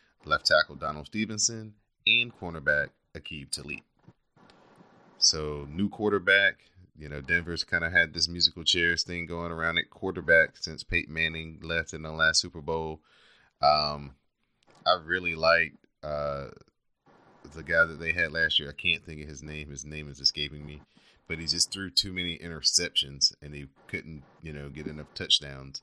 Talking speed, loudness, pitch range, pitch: 165 wpm, -26 LUFS, 75-85 Hz, 80 Hz